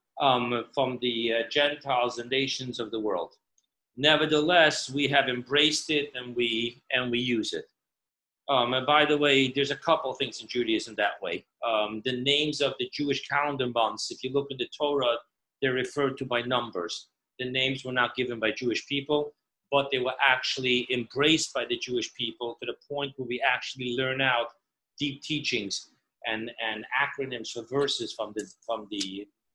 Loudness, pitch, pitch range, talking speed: -27 LUFS, 130 Hz, 120-145 Hz, 185 wpm